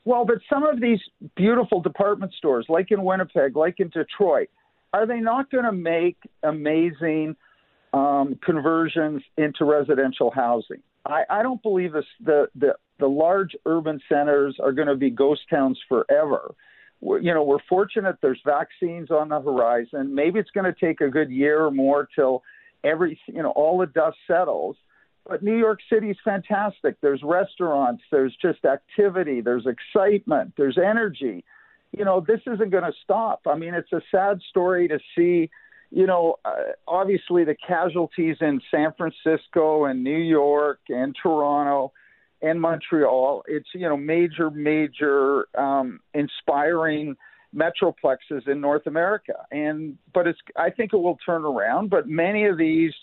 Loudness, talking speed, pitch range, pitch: -22 LUFS, 160 wpm, 145-195 Hz, 165 Hz